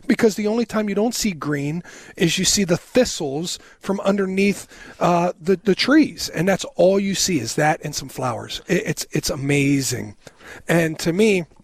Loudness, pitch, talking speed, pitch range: -20 LUFS, 180 Hz, 185 wpm, 150-200 Hz